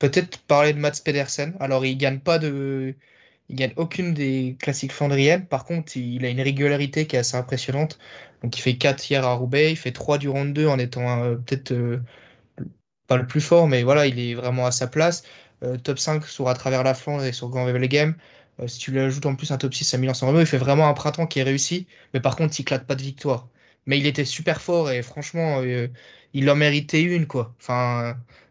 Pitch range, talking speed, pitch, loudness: 125-150 Hz, 240 wpm, 135 Hz, -22 LUFS